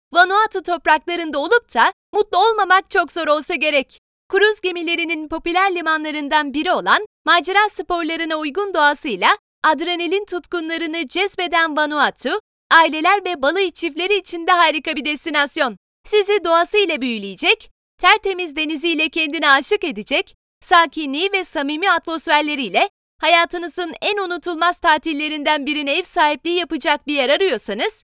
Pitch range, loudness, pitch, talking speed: 310-370 Hz, -17 LUFS, 335 Hz, 120 wpm